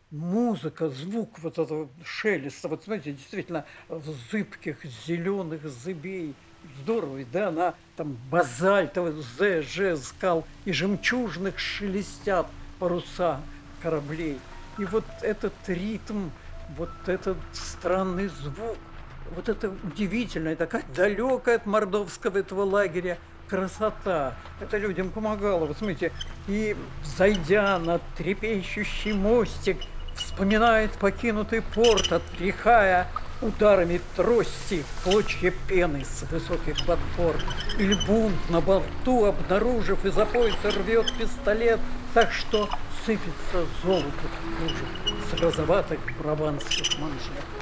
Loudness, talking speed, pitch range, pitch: -27 LUFS, 100 wpm, 165-210 Hz, 190 Hz